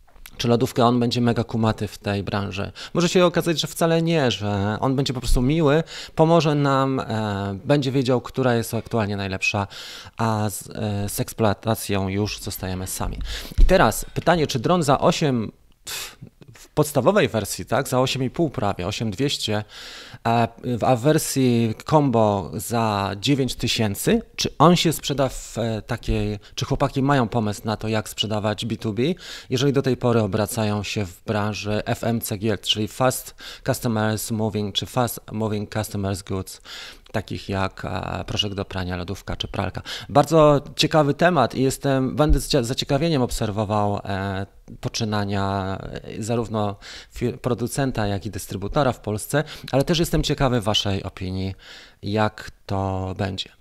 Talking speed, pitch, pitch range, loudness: 140 wpm, 115 Hz, 105-135 Hz, -22 LUFS